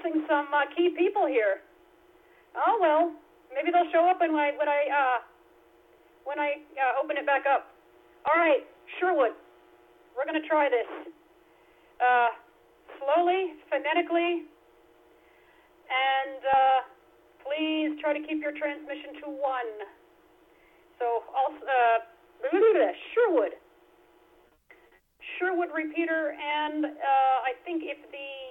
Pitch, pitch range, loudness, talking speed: 295 Hz, 270-335 Hz, -27 LUFS, 120 wpm